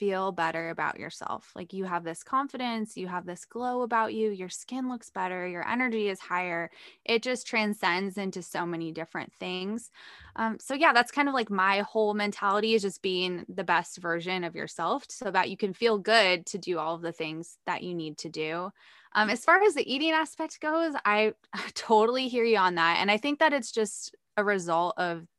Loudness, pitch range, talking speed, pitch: -28 LUFS, 180-235 Hz, 210 wpm, 200 Hz